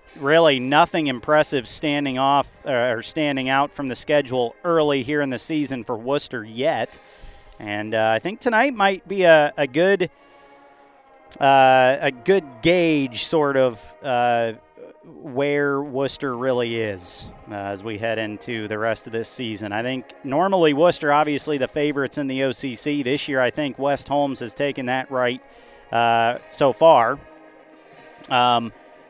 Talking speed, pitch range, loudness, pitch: 155 wpm, 120-145 Hz, -21 LUFS, 135 Hz